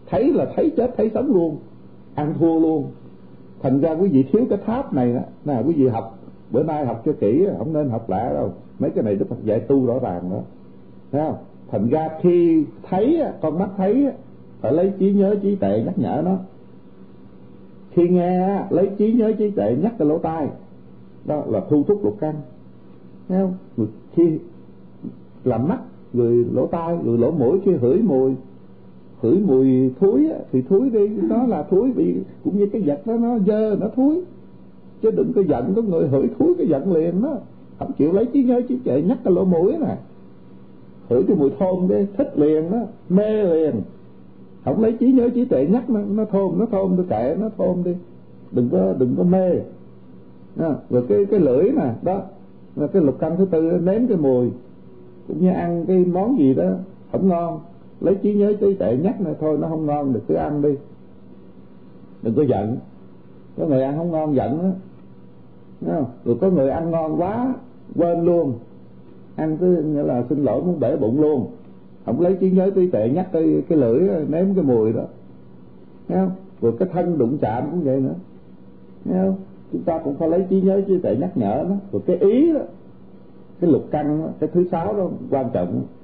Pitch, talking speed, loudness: 160 Hz, 200 wpm, -20 LUFS